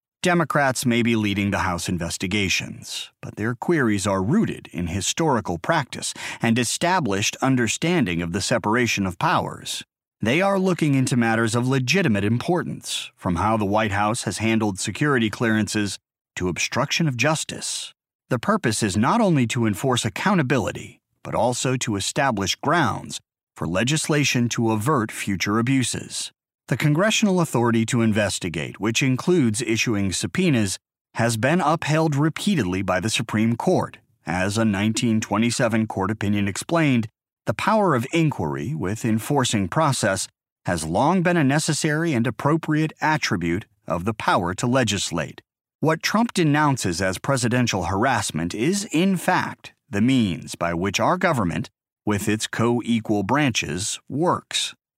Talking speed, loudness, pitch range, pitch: 140 wpm, -22 LUFS, 105-150 Hz, 115 Hz